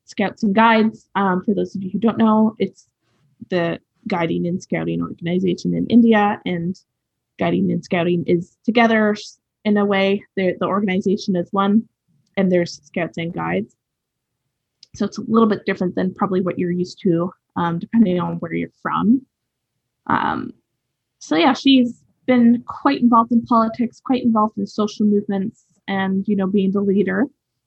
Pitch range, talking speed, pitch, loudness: 175-220 Hz, 165 wpm, 195 Hz, -19 LUFS